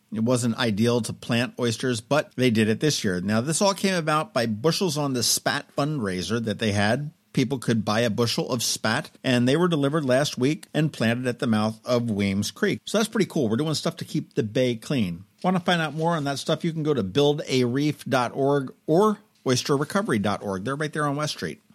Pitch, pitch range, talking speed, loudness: 130 Hz, 115-155 Hz, 220 wpm, -24 LUFS